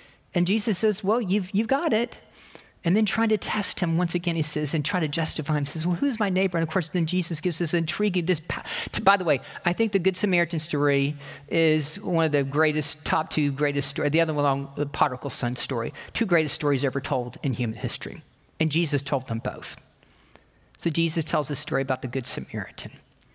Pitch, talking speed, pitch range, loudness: 160 Hz, 225 wpm, 145-185 Hz, -25 LUFS